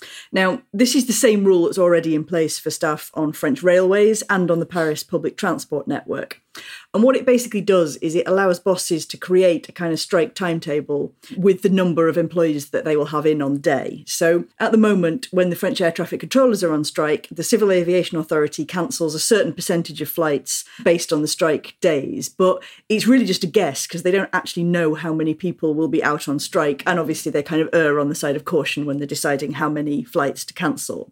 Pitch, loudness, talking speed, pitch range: 170 Hz, -19 LUFS, 225 wpm, 155-190 Hz